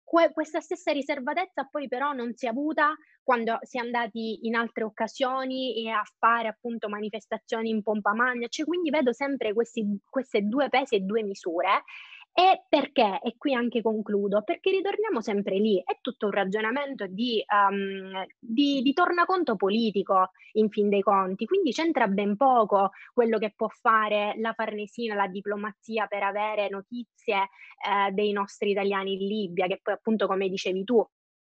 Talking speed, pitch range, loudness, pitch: 165 wpm, 205-265 Hz, -27 LUFS, 225 Hz